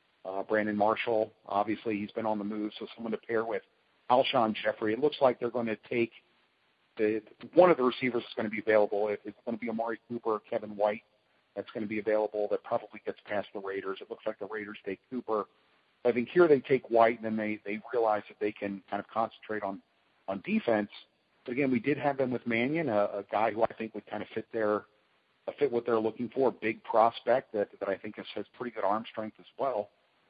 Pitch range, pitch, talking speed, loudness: 105-115 Hz, 110 Hz, 240 wpm, -31 LUFS